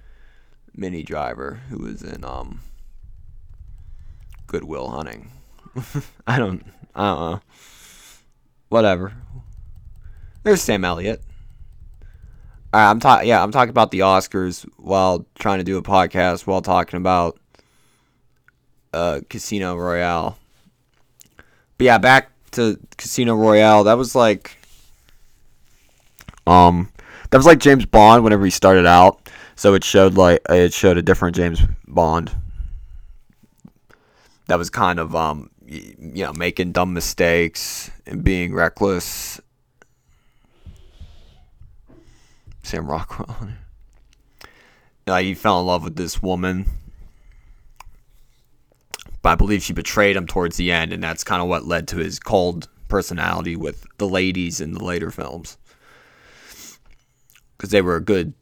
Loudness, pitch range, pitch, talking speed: -17 LUFS, 85-105 Hz, 90 Hz, 125 wpm